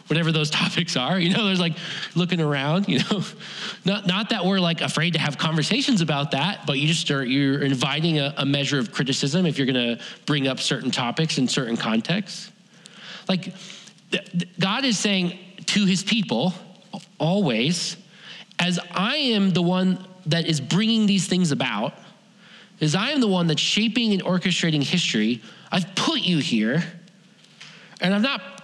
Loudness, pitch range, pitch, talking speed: -22 LUFS, 155-195 Hz, 180 Hz, 170 wpm